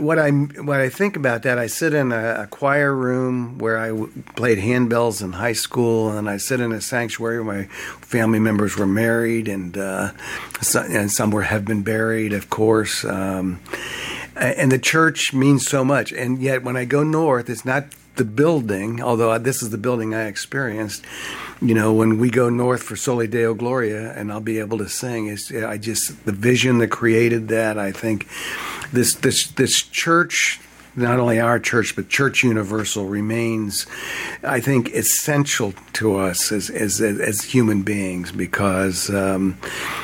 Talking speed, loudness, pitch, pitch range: 175 wpm, -20 LUFS, 115 Hz, 105-125 Hz